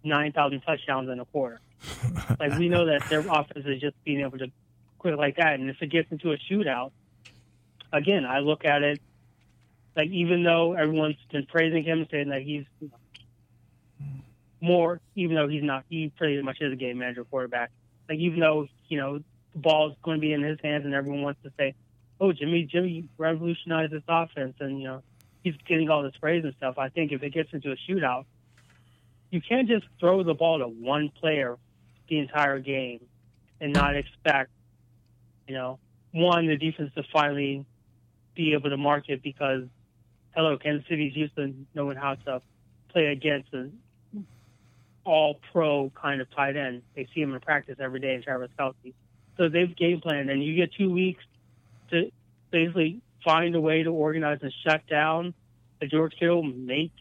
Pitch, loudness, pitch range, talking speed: 145 Hz, -27 LUFS, 125-160 Hz, 185 wpm